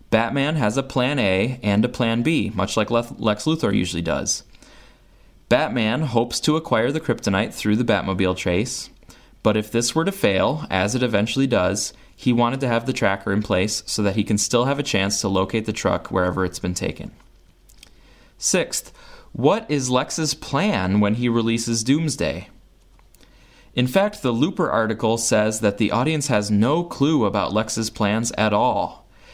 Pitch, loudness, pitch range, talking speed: 115 Hz, -21 LUFS, 105-125 Hz, 175 wpm